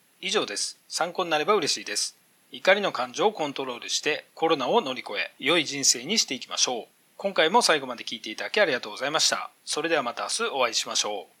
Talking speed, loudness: 480 characters per minute, -25 LUFS